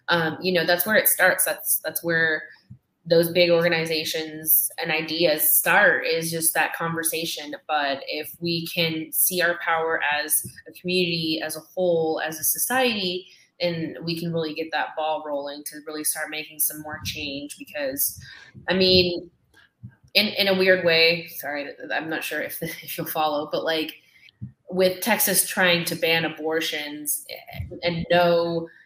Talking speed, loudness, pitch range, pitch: 160 wpm, -22 LUFS, 155-175 Hz, 165 Hz